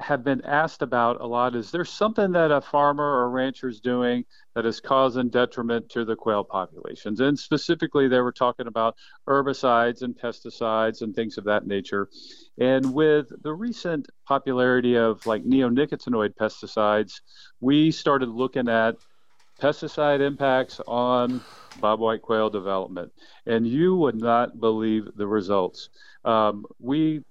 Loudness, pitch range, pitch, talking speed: -24 LUFS, 115-145 Hz, 125 Hz, 150 wpm